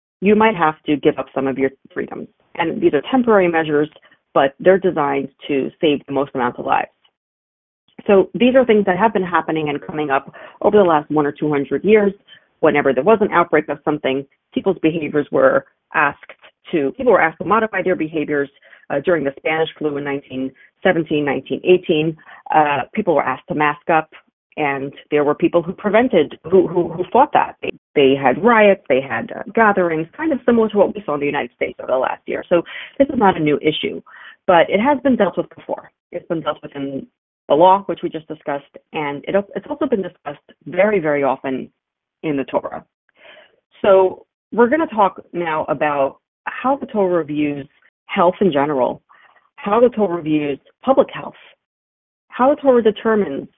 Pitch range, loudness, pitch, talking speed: 145-205 Hz, -17 LUFS, 170 Hz, 195 wpm